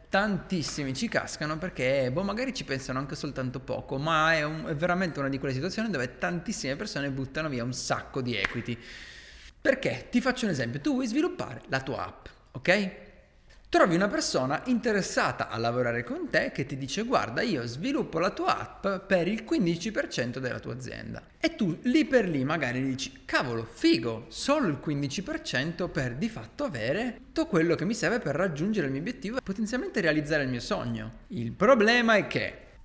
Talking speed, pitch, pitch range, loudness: 185 wpm, 170 Hz, 135-220 Hz, -29 LUFS